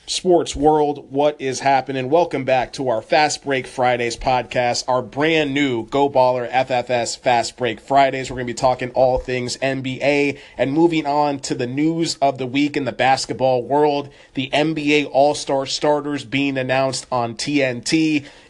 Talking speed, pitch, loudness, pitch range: 160 wpm, 135 Hz, -19 LUFS, 125-145 Hz